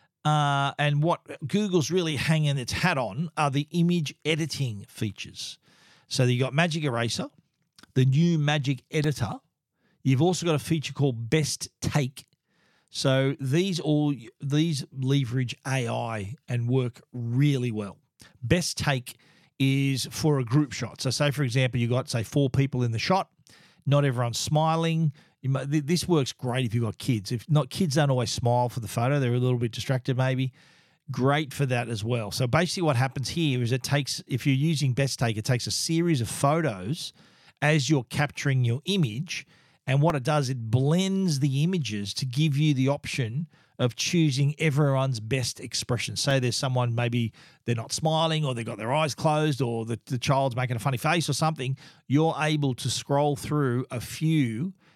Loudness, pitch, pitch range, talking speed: -26 LUFS, 140 Hz, 125-155 Hz, 180 wpm